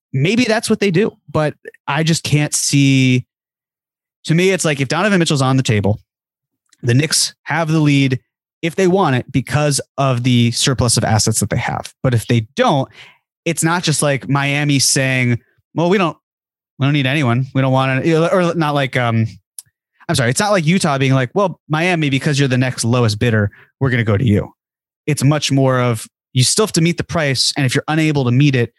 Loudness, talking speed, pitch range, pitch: -16 LUFS, 215 wpm, 125-160 Hz, 140 Hz